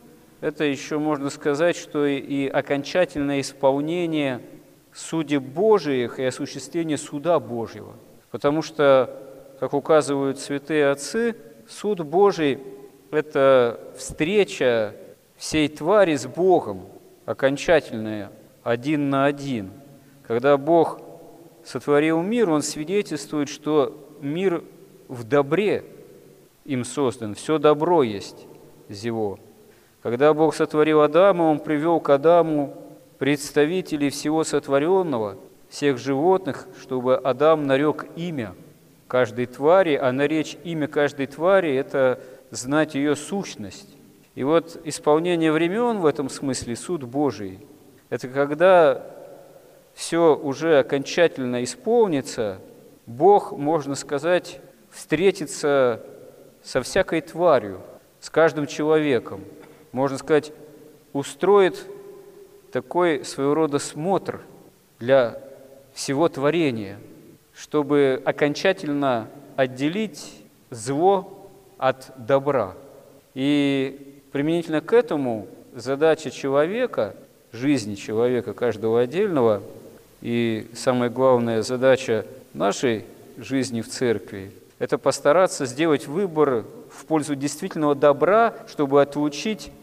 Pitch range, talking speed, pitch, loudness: 135-160 Hz, 100 wpm, 145 Hz, -22 LUFS